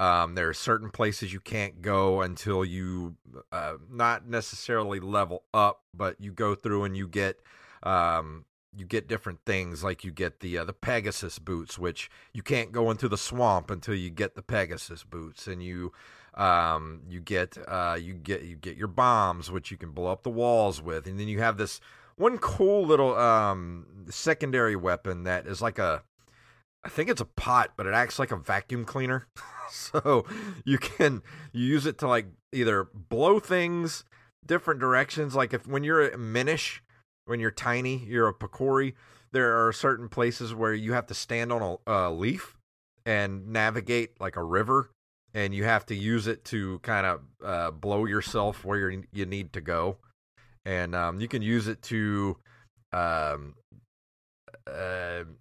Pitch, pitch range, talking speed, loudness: 105 Hz, 90-120 Hz, 180 wpm, -28 LUFS